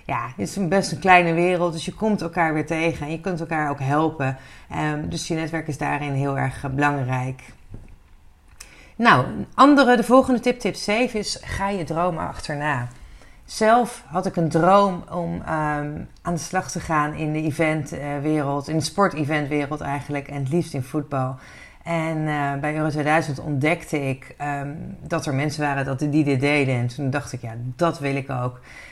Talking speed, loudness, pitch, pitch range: 185 wpm, -22 LUFS, 150 Hz, 140-170 Hz